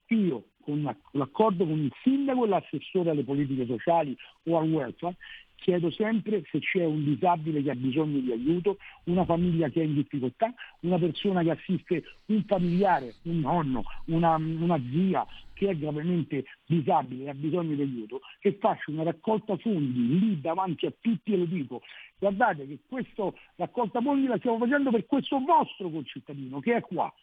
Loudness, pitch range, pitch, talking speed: -28 LUFS, 150-205 Hz, 170 Hz, 170 wpm